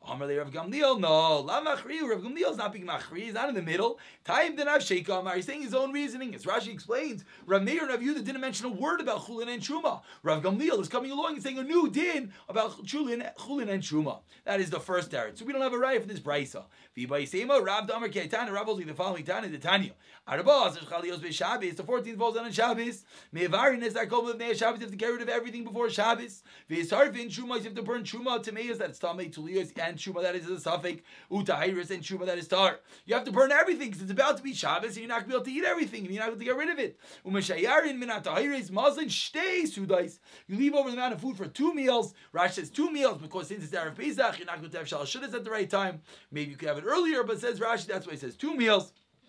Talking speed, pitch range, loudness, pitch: 250 wpm, 185-265 Hz, -30 LUFS, 225 Hz